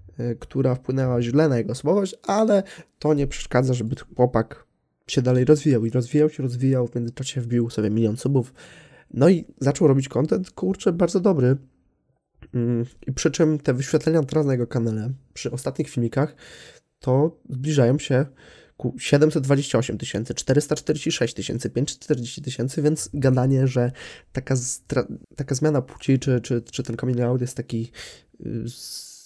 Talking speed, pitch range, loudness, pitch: 150 wpm, 120-150 Hz, -23 LUFS, 130 Hz